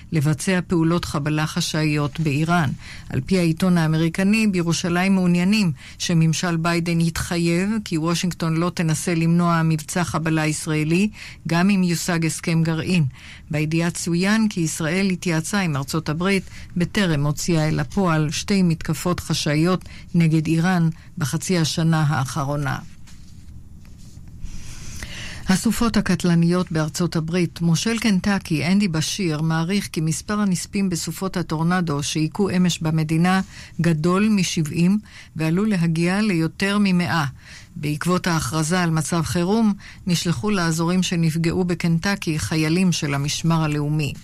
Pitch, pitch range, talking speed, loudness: 170 Hz, 155-180 Hz, 115 wpm, -21 LUFS